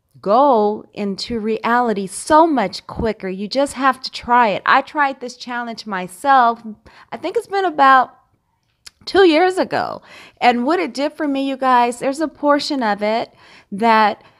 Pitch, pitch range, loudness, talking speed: 245 Hz, 220-290 Hz, -17 LUFS, 165 wpm